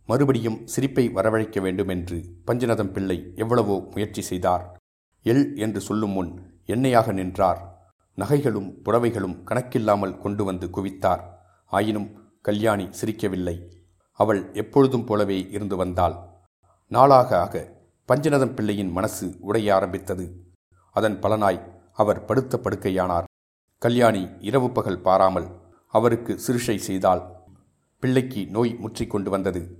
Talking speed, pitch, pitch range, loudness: 110 wpm, 100 Hz, 90-115 Hz, -23 LUFS